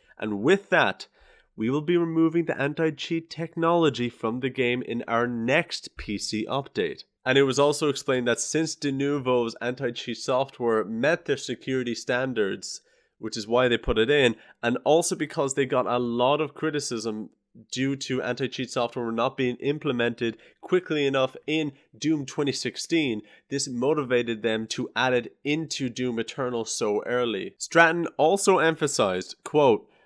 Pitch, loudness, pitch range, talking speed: 130 Hz, -26 LUFS, 120-150 Hz, 155 wpm